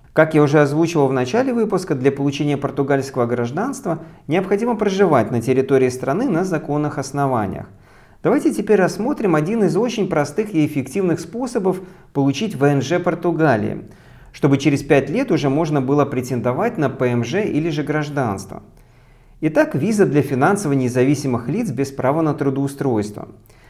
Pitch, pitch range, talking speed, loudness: 145 Hz, 135-175 Hz, 140 wpm, -19 LUFS